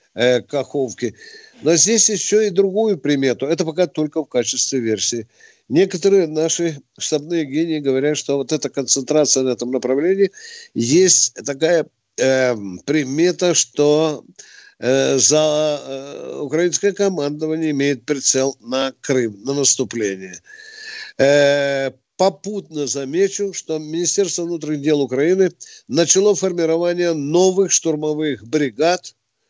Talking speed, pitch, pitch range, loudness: 110 wpm, 155 Hz, 135-180 Hz, -18 LUFS